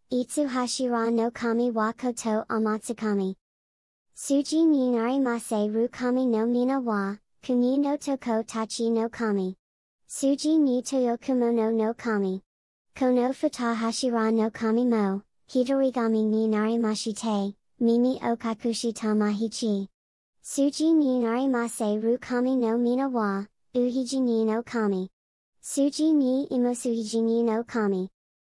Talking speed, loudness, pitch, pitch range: 270 characters per minute, -26 LUFS, 235 Hz, 220-255 Hz